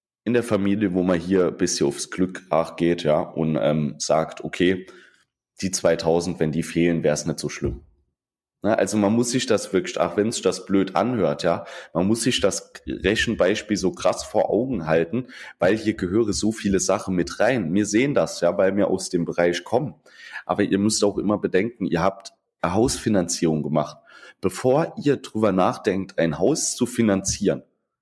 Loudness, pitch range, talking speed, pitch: -22 LUFS, 80-105 Hz, 190 wpm, 95 Hz